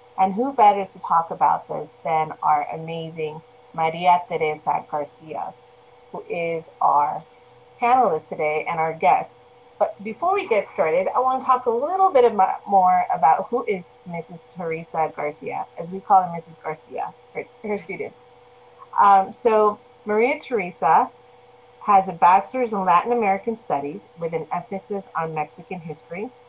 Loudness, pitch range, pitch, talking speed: -21 LUFS, 160-230 Hz, 190 Hz, 145 wpm